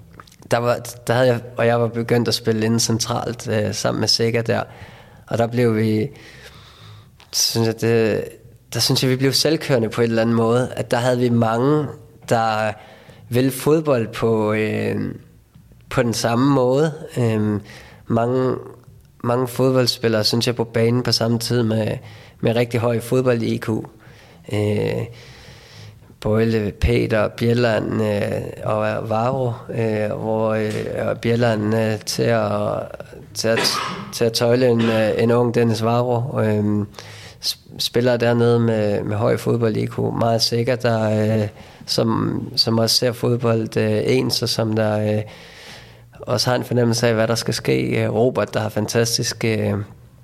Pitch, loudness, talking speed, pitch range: 115 Hz, -19 LUFS, 150 wpm, 110-120 Hz